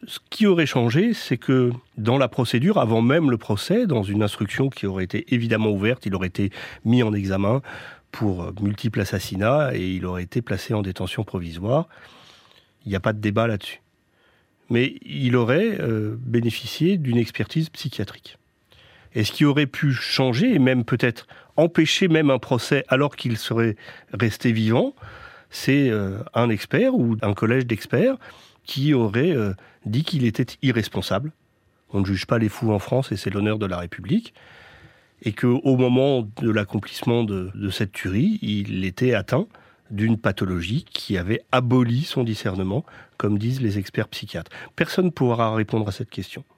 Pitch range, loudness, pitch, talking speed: 105-130 Hz, -22 LUFS, 115 Hz, 165 wpm